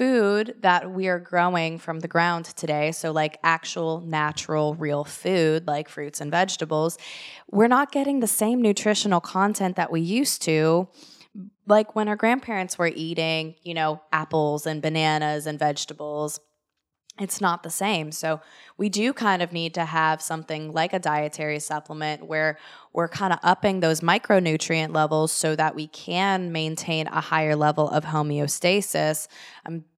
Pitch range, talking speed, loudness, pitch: 155-185 Hz, 160 wpm, -24 LUFS, 160 Hz